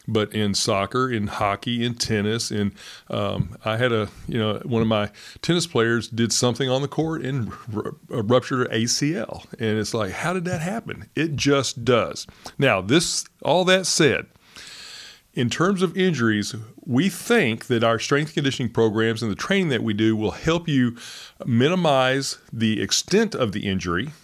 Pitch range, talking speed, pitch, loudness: 110-150 Hz, 170 wpm, 120 Hz, -22 LUFS